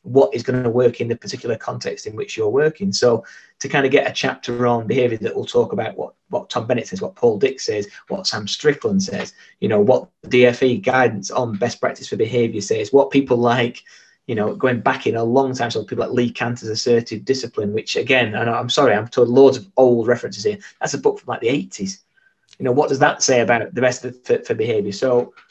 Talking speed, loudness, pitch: 235 wpm, -19 LUFS, 130 Hz